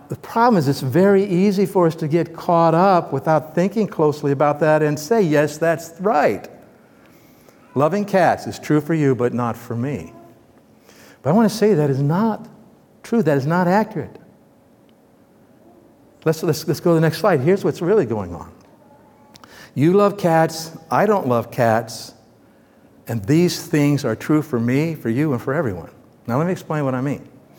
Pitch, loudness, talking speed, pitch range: 160 Hz, -19 LUFS, 185 wpm, 140-180 Hz